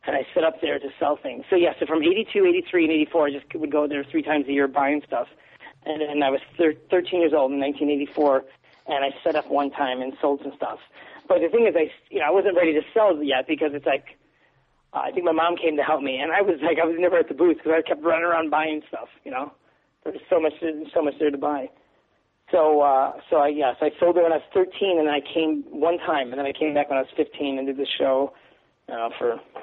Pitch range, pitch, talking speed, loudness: 140-170 Hz, 155 Hz, 280 wpm, -23 LUFS